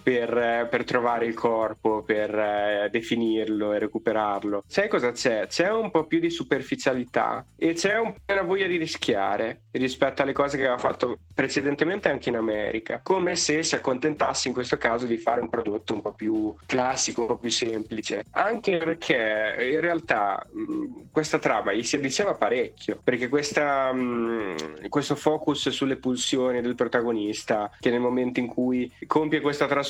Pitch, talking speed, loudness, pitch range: 125 Hz, 170 wpm, -25 LUFS, 115-150 Hz